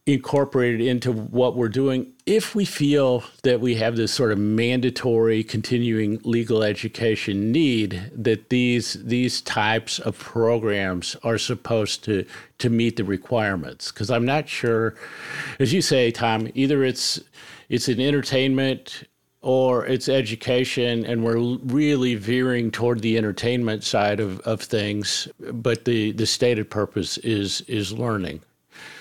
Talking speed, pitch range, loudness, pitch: 140 wpm, 110-125 Hz, -22 LUFS, 115 Hz